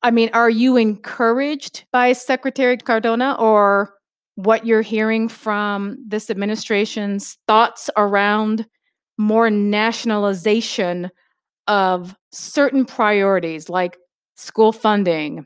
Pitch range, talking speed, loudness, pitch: 205-230 Hz, 95 wpm, -18 LUFS, 220 Hz